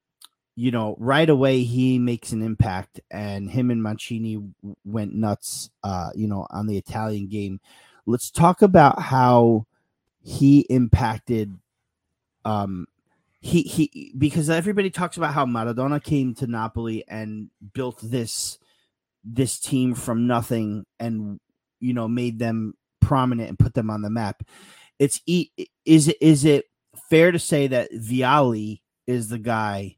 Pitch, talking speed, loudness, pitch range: 120 Hz, 145 wpm, -22 LUFS, 105-135 Hz